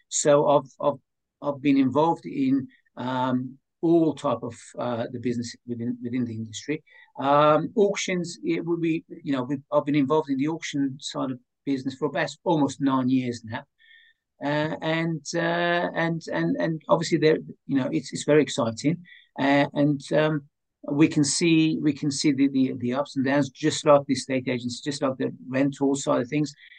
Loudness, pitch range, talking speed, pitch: -25 LUFS, 135-160 Hz, 180 wpm, 145 Hz